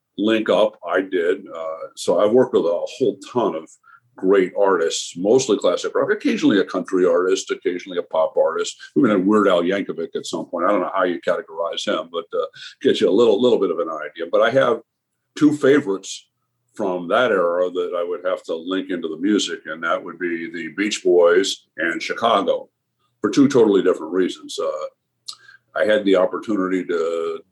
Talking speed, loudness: 195 wpm, -20 LUFS